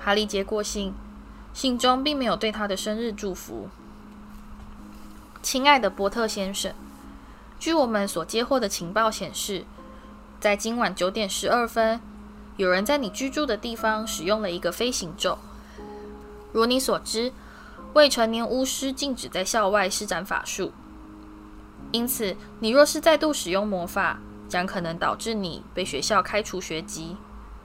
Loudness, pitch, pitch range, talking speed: -25 LUFS, 210 Hz, 180-230 Hz, 220 characters per minute